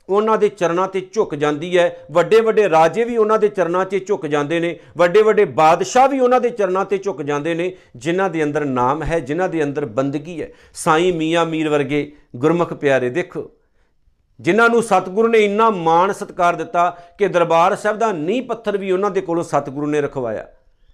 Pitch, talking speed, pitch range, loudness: 175 Hz, 190 wpm, 155-205 Hz, -17 LUFS